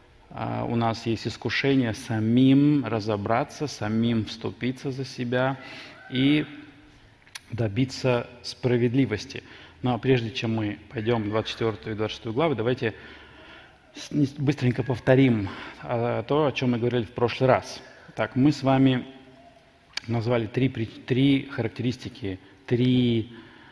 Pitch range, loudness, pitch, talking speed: 115-135 Hz, -25 LUFS, 125 Hz, 110 wpm